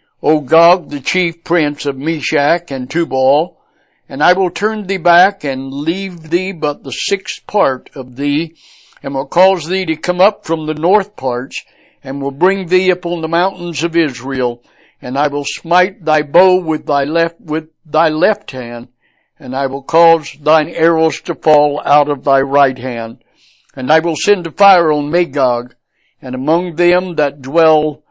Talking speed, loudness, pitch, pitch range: 175 wpm, -14 LUFS, 160 Hz, 140-175 Hz